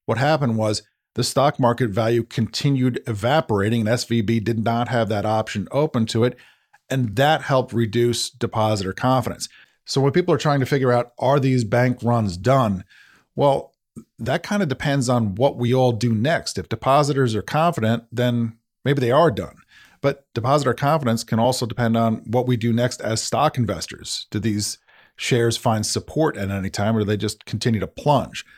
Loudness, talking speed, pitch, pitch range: -21 LUFS, 185 wpm, 120 Hz, 110-130 Hz